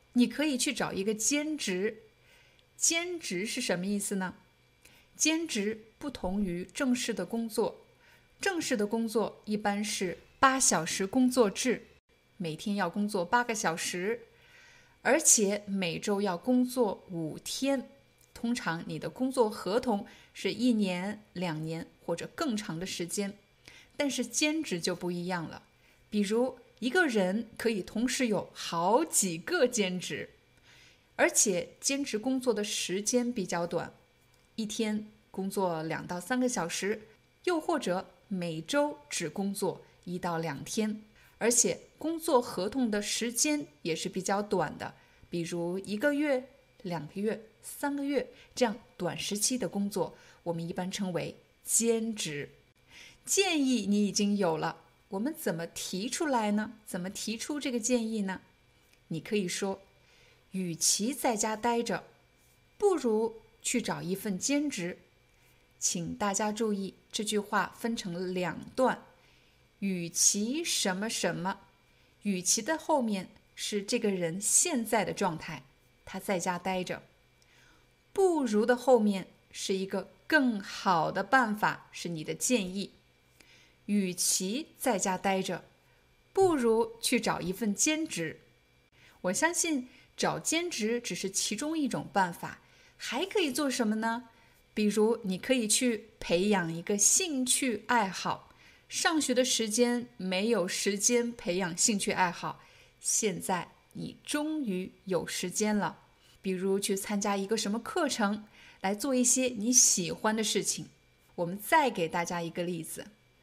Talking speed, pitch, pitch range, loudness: 200 characters per minute, 210 Hz, 185-245 Hz, -30 LUFS